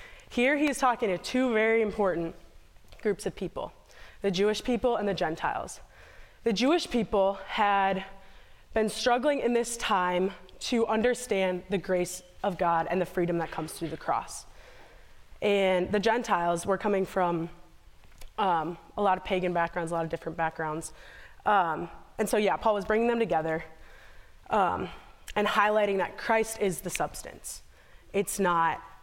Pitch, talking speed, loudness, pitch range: 195 Hz, 155 wpm, -28 LUFS, 170-220 Hz